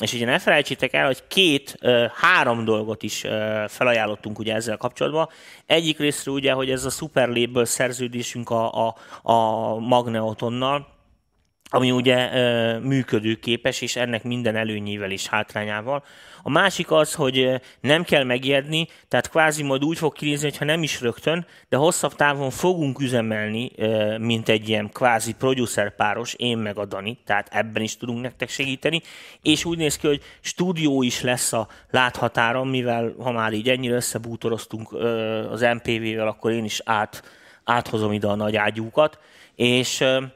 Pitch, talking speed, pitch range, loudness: 120 Hz, 150 wpm, 110-135 Hz, -22 LUFS